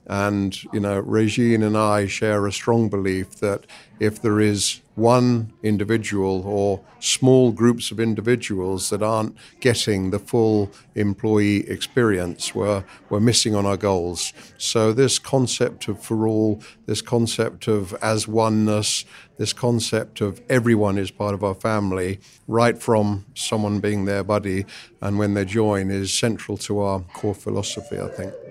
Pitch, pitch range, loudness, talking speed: 105 Hz, 100-115 Hz, -21 LUFS, 150 wpm